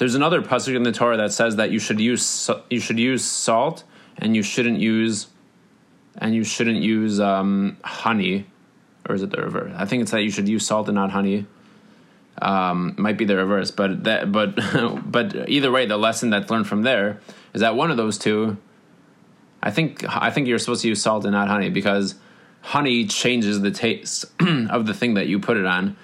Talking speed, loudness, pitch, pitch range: 205 wpm, -21 LUFS, 110 Hz, 100-115 Hz